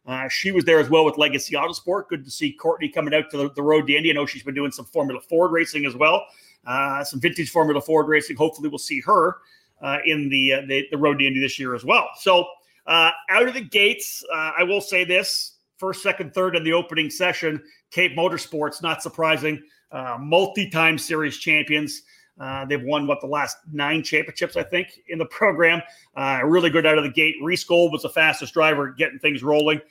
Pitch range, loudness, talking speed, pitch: 150-175 Hz, -20 LUFS, 220 wpm, 160 Hz